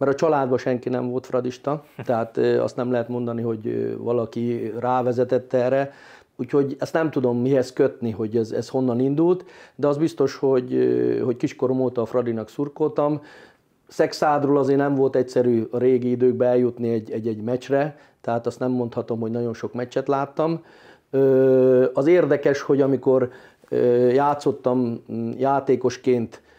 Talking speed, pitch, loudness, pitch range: 145 wpm, 125 Hz, -22 LUFS, 120-140 Hz